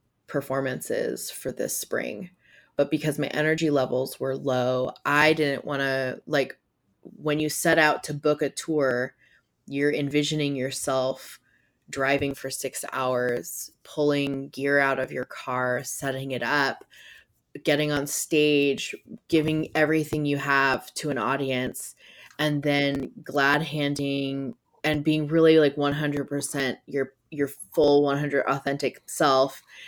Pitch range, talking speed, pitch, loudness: 135-150 Hz, 130 wpm, 140 Hz, -25 LUFS